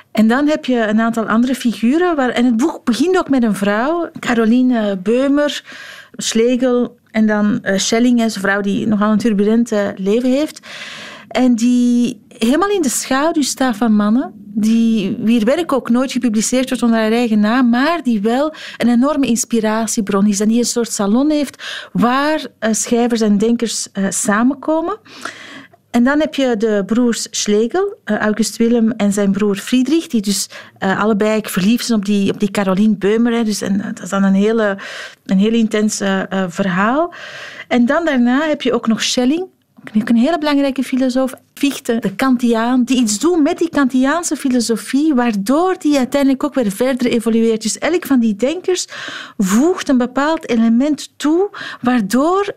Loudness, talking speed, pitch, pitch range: -15 LUFS, 160 wpm, 235 Hz, 220-275 Hz